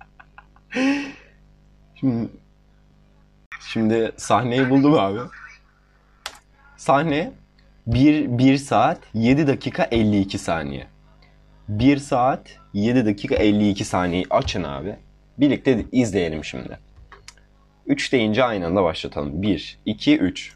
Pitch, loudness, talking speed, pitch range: 120 Hz, -21 LUFS, 95 wpm, 105-140 Hz